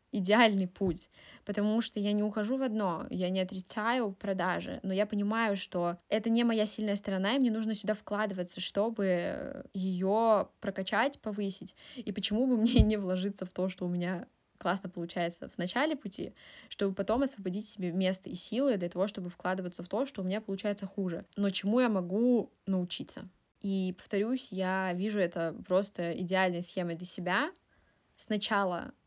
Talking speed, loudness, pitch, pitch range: 165 wpm, -32 LUFS, 200 Hz, 185-215 Hz